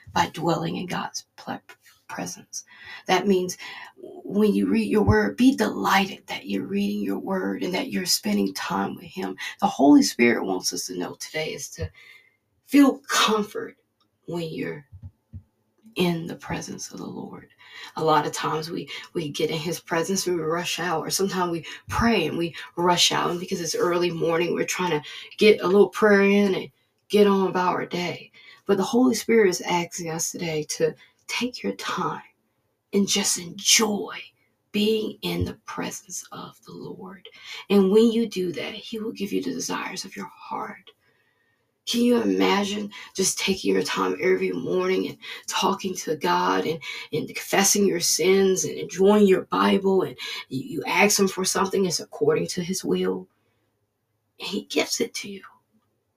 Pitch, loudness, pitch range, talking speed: 180 Hz, -23 LUFS, 125-205 Hz, 170 wpm